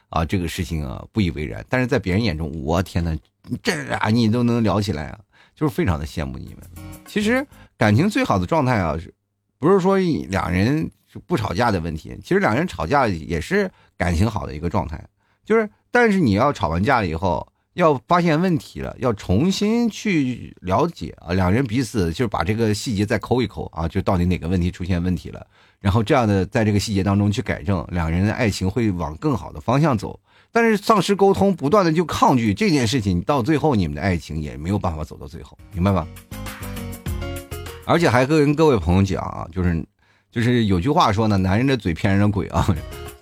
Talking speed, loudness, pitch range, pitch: 310 characters per minute, -20 LUFS, 90-125 Hz, 100 Hz